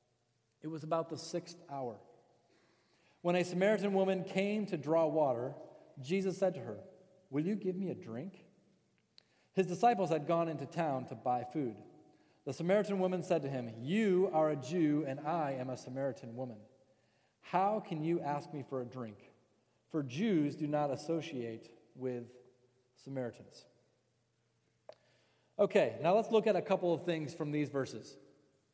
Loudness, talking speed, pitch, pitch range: -35 LUFS, 160 wpm, 155 Hz, 130-185 Hz